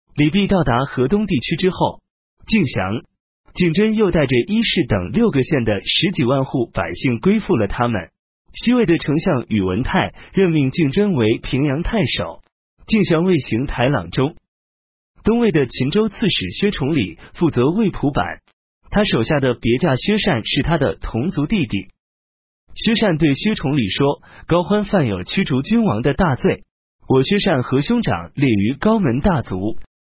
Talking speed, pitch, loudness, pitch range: 240 characters per minute, 145 Hz, -18 LUFS, 115-195 Hz